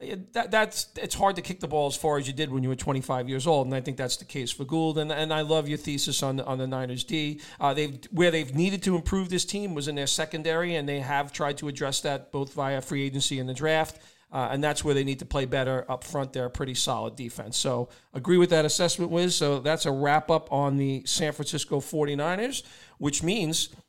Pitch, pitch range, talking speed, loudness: 145 Hz, 135-160 Hz, 250 wpm, -27 LUFS